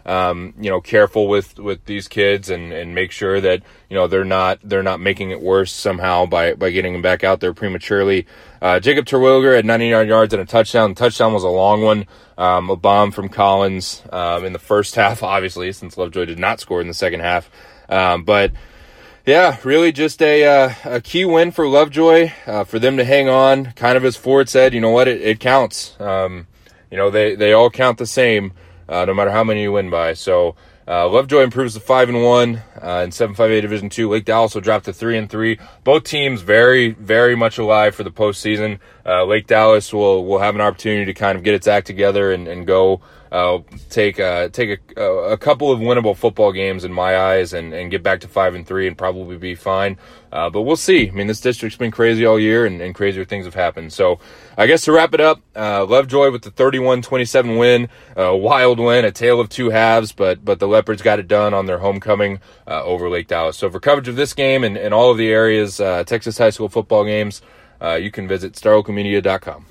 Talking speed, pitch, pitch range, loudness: 230 wpm, 105 Hz, 95-120 Hz, -16 LUFS